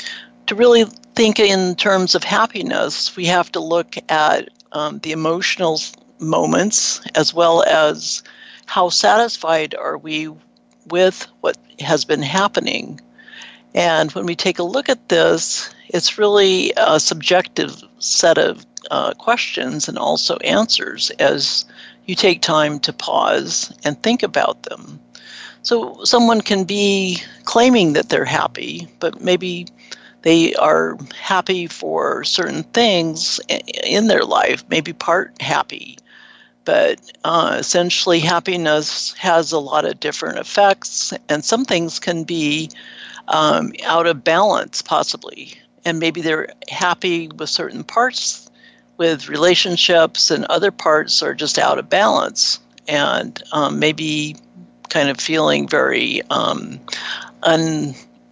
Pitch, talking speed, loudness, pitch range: 170 Hz, 130 wpm, -17 LUFS, 150-185 Hz